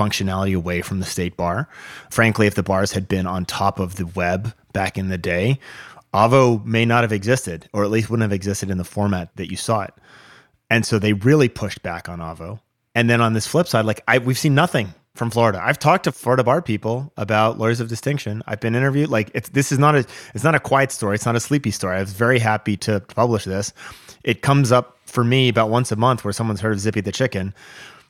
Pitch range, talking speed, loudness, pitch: 100-125 Hz, 240 wpm, -20 LUFS, 110 Hz